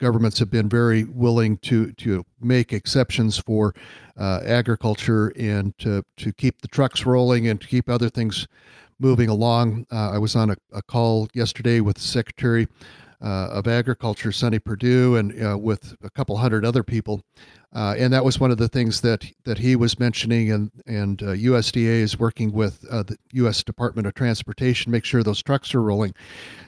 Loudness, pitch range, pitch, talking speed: -22 LUFS, 105-120 Hz, 115 Hz, 185 wpm